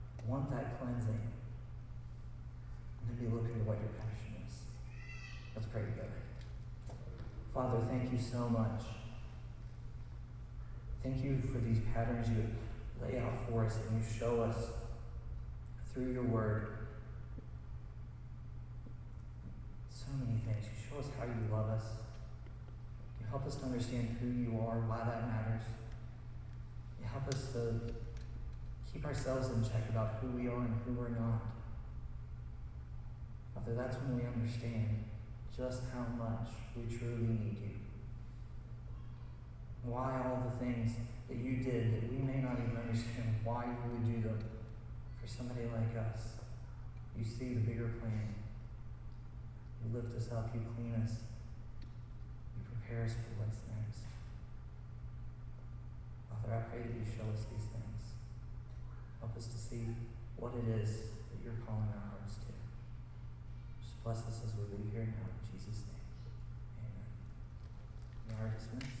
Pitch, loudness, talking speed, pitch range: 115 Hz, -42 LUFS, 145 wpm, 110-120 Hz